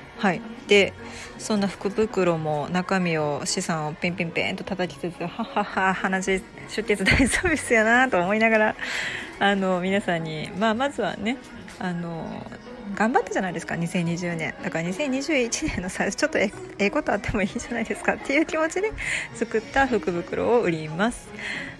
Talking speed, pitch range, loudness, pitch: 330 characters per minute, 180-230 Hz, -24 LUFS, 200 Hz